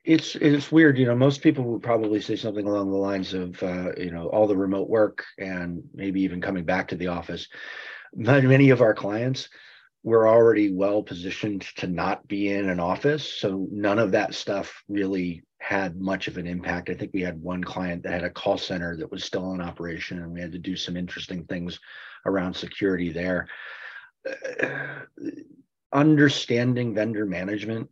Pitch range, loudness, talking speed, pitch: 90-120 Hz, -24 LUFS, 185 wpm, 100 Hz